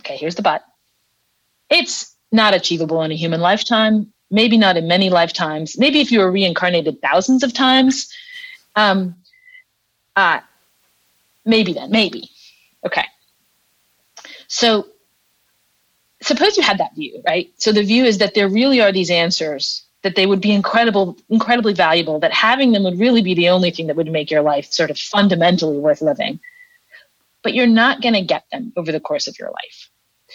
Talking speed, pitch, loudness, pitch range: 170 wpm, 205 Hz, -16 LUFS, 175-245 Hz